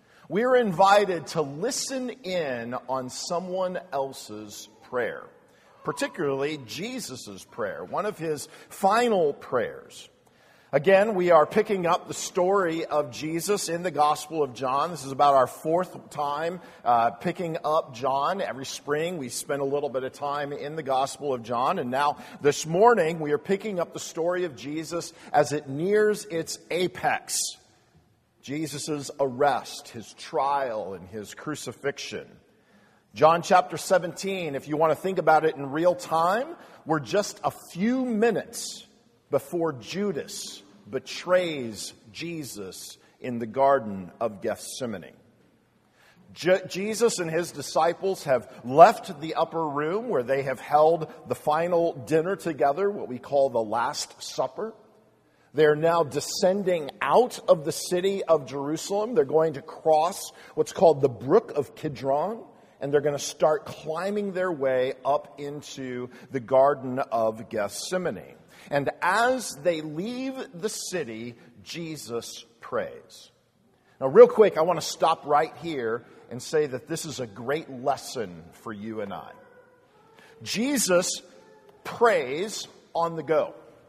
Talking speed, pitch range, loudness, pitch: 140 wpm, 135-185 Hz, -26 LUFS, 155 Hz